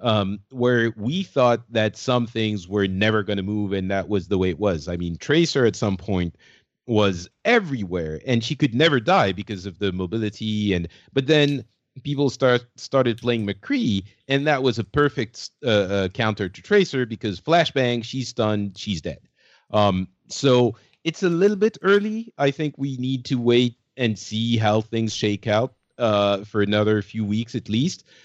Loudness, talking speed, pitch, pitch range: -22 LUFS, 180 wpm, 115 Hz, 100-130 Hz